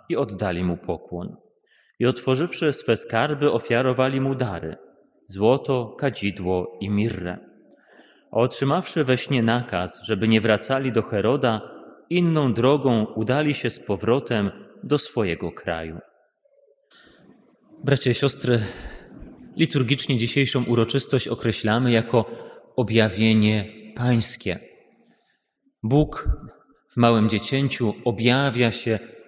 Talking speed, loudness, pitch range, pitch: 100 wpm, -22 LUFS, 110-135 Hz, 120 Hz